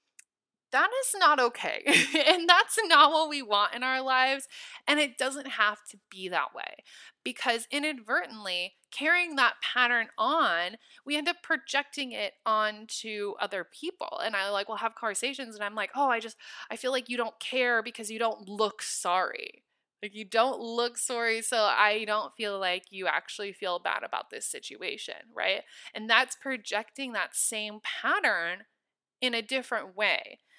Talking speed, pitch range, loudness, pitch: 170 wpm, 210-285 Hz, -28 LUFS, 235 Hz